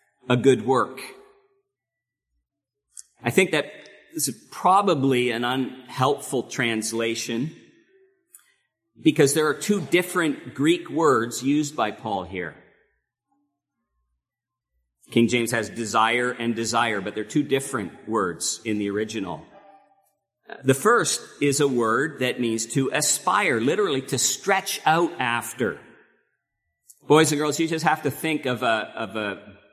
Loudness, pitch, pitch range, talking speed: -23 LUFS, 135 Hz, 115-165 Hz, 125 wpm